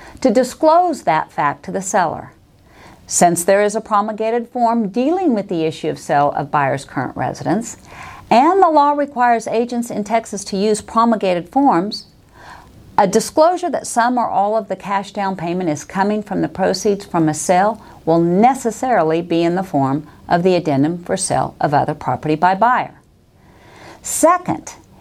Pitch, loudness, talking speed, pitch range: 210 Hz, -17 LUFS, 170 wpm, 175-240 Hz